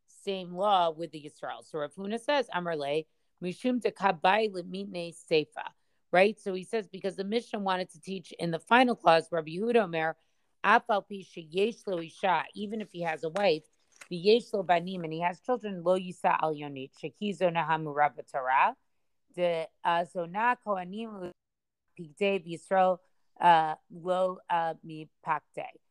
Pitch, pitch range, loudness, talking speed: 180 Hz, 165-200 Hz, -29 LUFS, 130 wpm